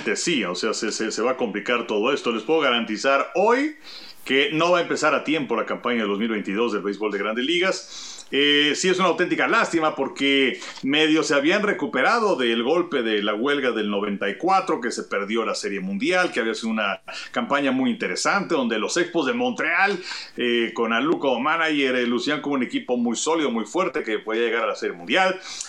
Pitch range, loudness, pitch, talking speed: 120-180 Hz, -22 LUFS, 145 Hz, 205 wpm